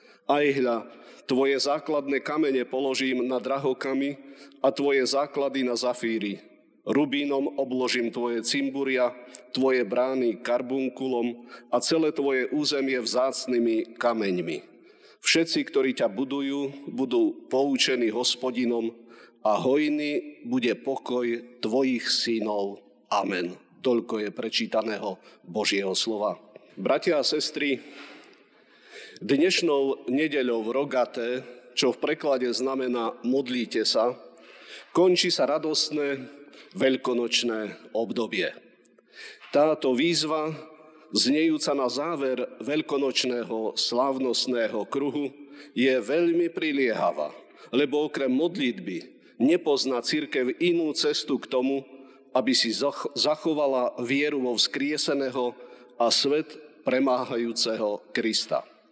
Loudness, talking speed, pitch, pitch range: -26 LUFS, 95 wpm, 135 Hz, 125-145 Hz